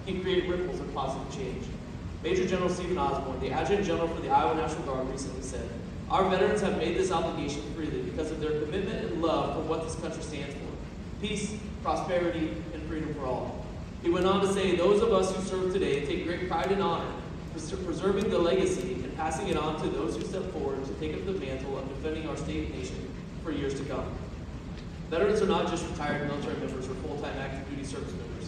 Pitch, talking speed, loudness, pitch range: 165 Hz, 215 wpm, -31 LUFS, 145-185 Hz